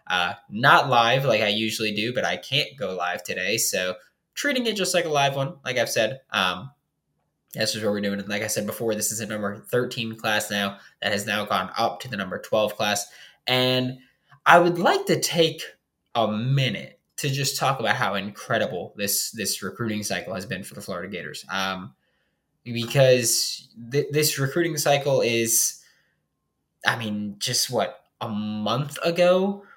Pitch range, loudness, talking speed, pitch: 105-145 Hz, -23 LUFS, 180 wpm, 120 Hz